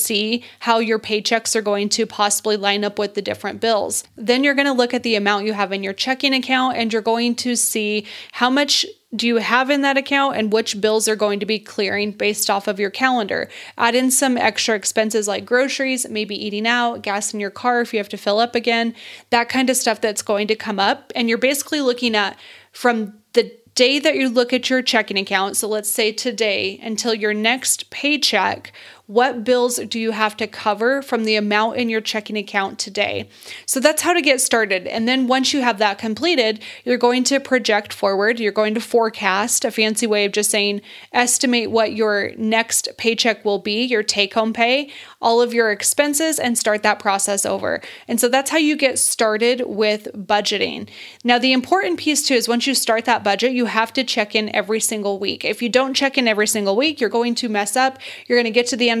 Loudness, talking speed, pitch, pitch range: -18 LUFS, 225 wpm, 230 Hz, 210-250 Hz